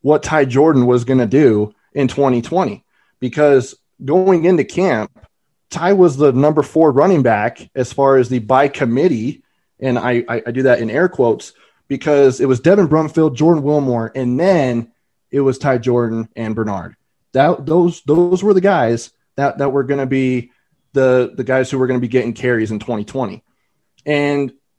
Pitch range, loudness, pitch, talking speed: 125-150 Hz, -15 LUFS, 135 Hz, 180 wpm